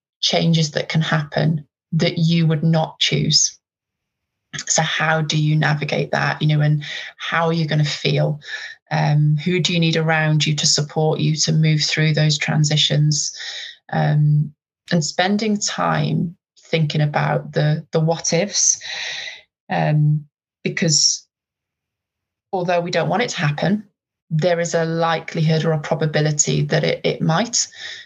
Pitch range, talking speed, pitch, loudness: 150-170 Hz, 150 wpm, 160 Hz, -19 LUFS